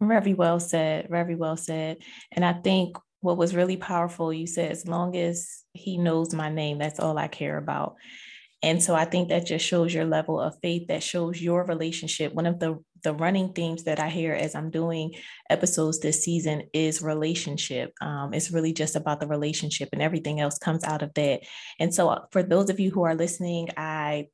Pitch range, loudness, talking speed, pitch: 155-175 Hz, -26 LUFS, 205 wpm, 165 Hz